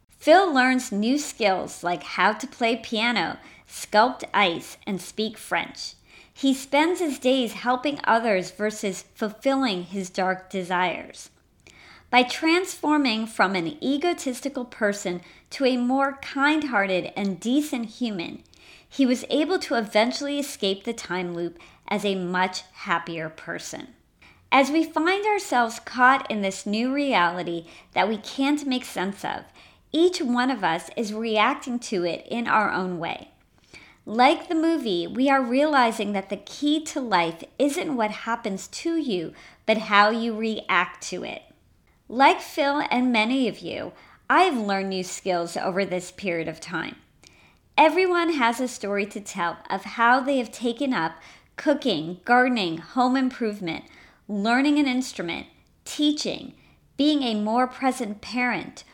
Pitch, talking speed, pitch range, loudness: 235 Hz, 145 wpm, 195-275 Hz, -24 LUFS